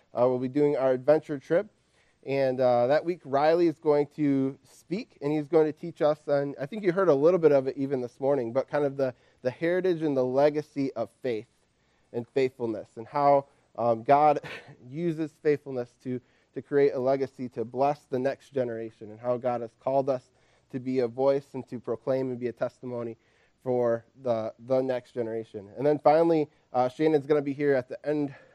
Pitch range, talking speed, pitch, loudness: 125-145 Hz, 210 wpm, 135 Hz, -27 LUFS